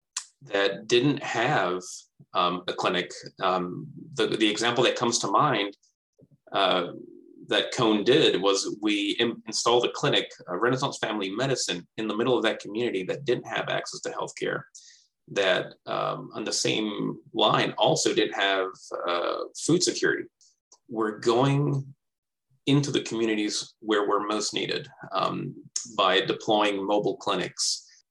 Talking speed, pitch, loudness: 140 wpm, 130 Hz, -26 LUFS